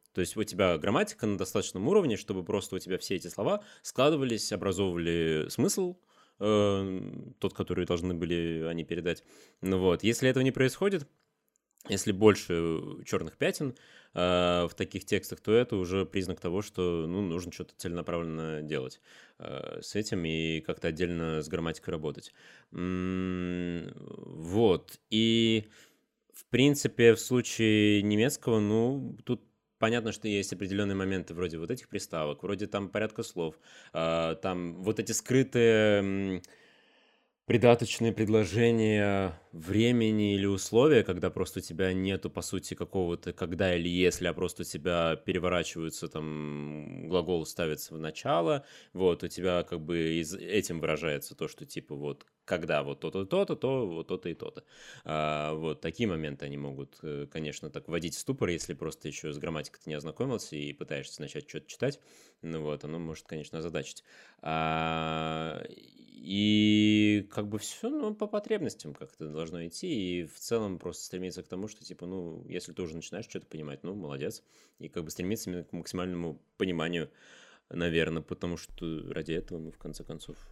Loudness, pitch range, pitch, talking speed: -31 LUFS, 80-105 Hz, 90 Hz, 150 wpm